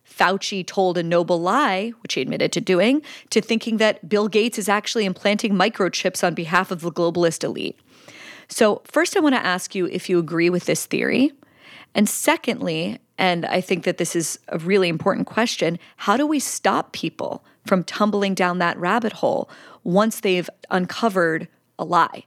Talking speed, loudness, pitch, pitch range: 180 wpm, -21 LUFS, 195 Hz, 180-225 Hz